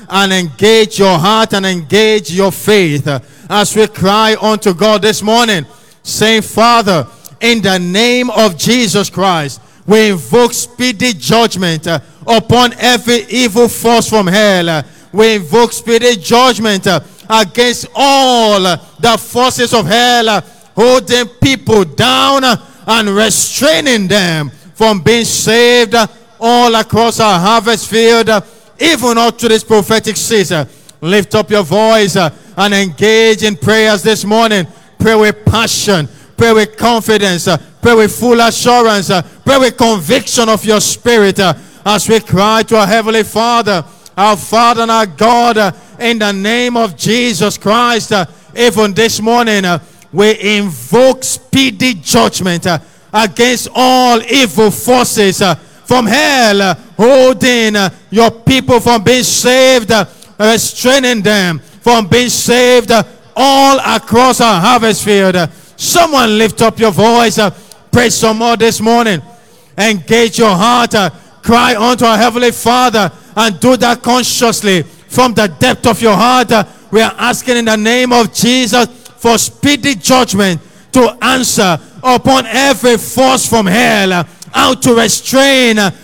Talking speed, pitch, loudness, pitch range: 150 wpm, 220 Hz, -9 LUFS, 200-240 Hz